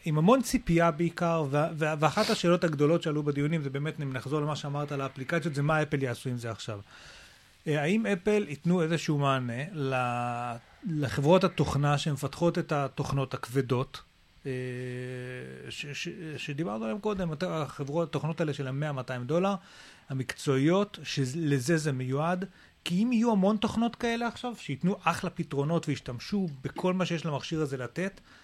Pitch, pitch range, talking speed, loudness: 150 Hz, 135-175 Hz, 150 wpm, -30 LUFS